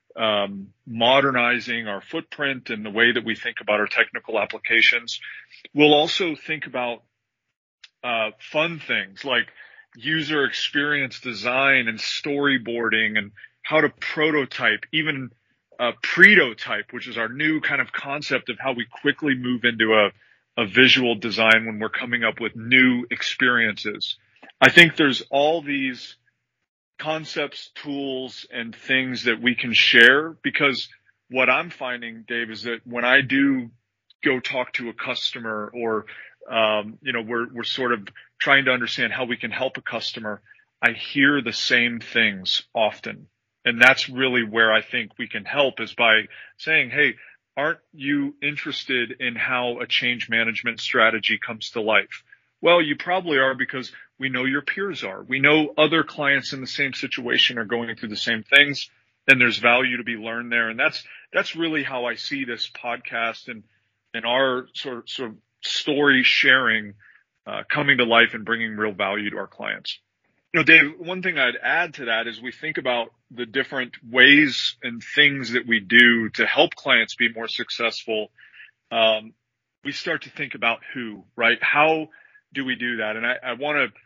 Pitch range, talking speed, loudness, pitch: 115-140 Hz, 175 wpm, -20 LUFS, 125 Hz